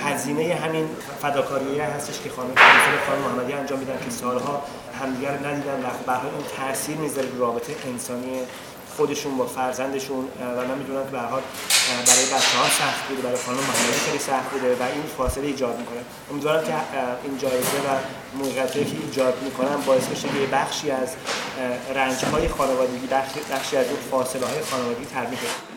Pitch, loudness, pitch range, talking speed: 135 Hz, -23 LUFS, 125-140 Hz, 160 wpm